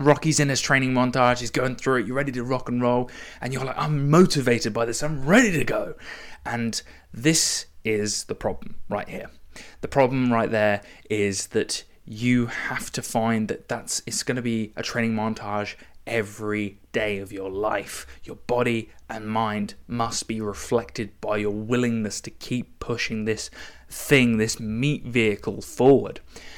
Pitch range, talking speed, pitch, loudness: 110-130 Hz, 170 wpm, 115 Hz, -24 LUFS